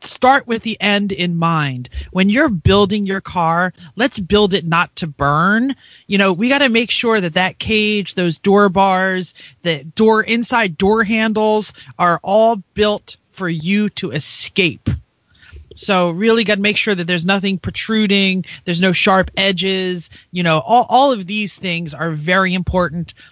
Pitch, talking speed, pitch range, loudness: 195 Hz, 170 wpm, 175-215 Hz, -15 LUFS